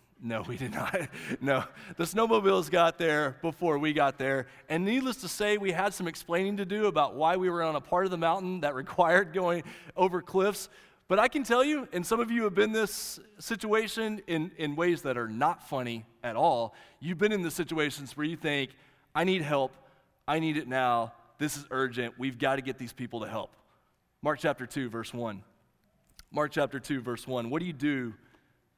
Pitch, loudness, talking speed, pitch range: 155 Hz, -30 LUFS, 210 wpm, 135-185 Hz